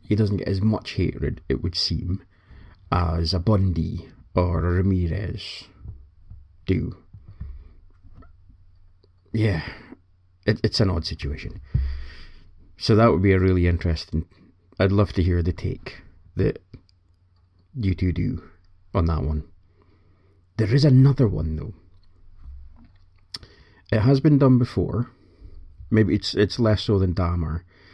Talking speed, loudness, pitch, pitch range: 125 wpm, -23 LUFS, 90 Hz, 85-100 Hz